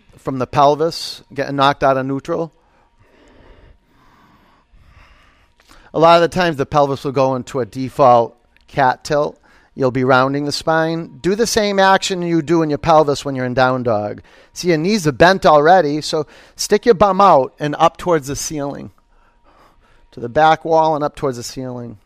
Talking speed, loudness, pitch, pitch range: 180 wpm, -15 LUFS, 145 Hz, 130-165 Hz